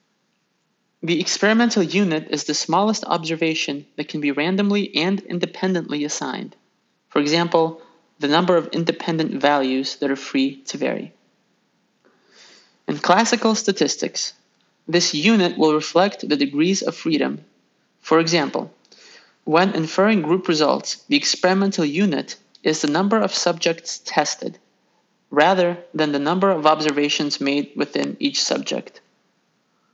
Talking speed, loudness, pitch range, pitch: 125 wpm, -20 LUFS, 150-195 Hz, 170 Hz